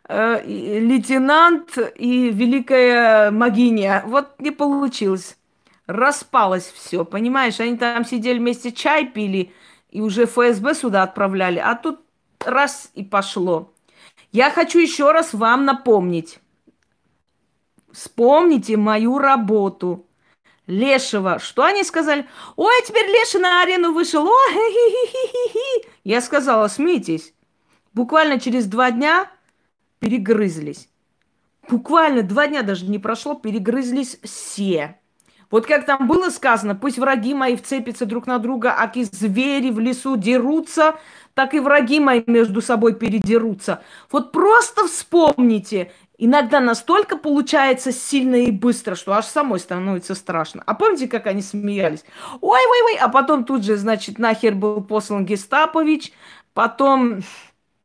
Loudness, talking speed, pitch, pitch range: -17 LUFS, 120 wpm, 245 Hz, 215-290 Hz